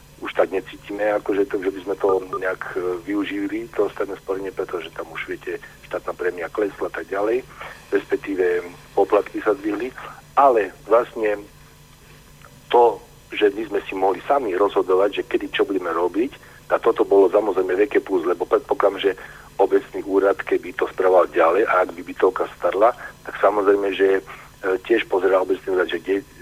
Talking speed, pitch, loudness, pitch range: 165 wpm, 390 Hz, -21 LUFS, 330-420 Hz